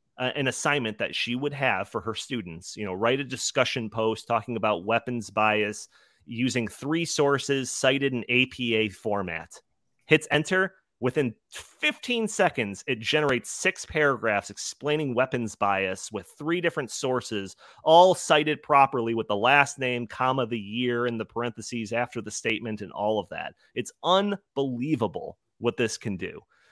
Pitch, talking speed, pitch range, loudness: 125 Hz, 155 wpm, 110-140 Hz, -26 LUFS